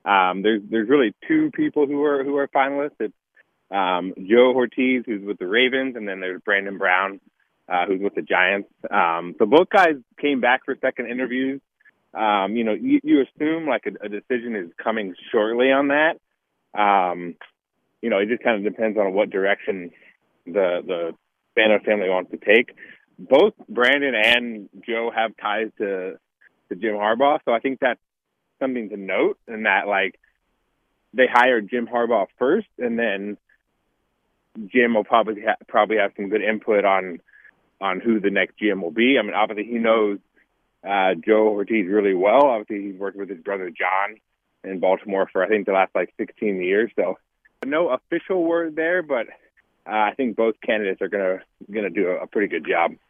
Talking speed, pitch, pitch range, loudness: 185 wpm, 110 Hz, 100-130 Hz, -21 LUFS